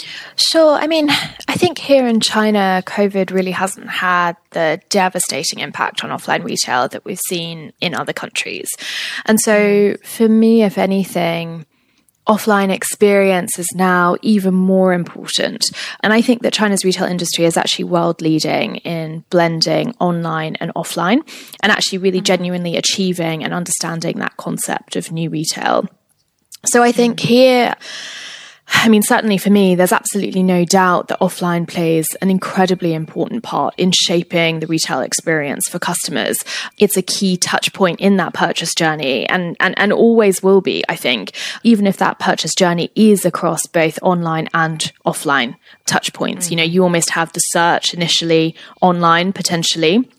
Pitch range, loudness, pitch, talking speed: 170-210 Hz, -15 LUFS, 185 Hz, 160 wpm